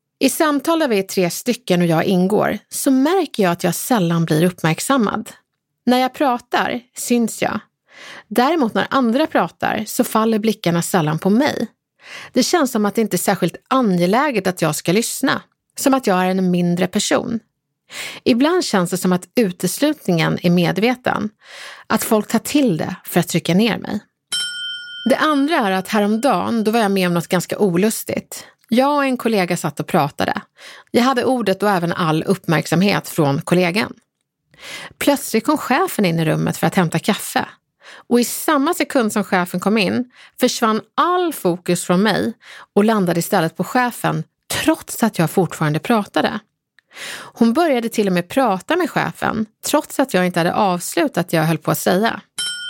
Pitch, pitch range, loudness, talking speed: 210 Hz, 180-255 Hz, -18 LUFS, 175 wpm